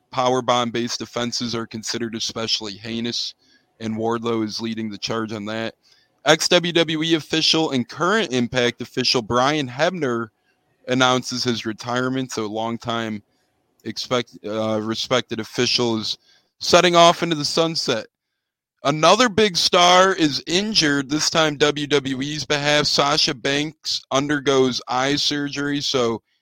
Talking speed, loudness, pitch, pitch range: 115 wpm, -20 LUFS, 125 Hz, 115-150 Hz